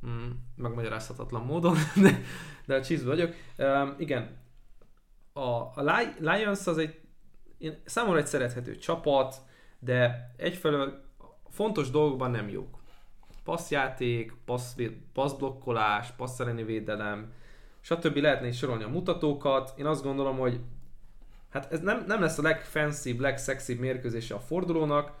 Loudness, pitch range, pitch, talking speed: -30 LUFS, 120-155 Hz, 135 Hz, 125 wpm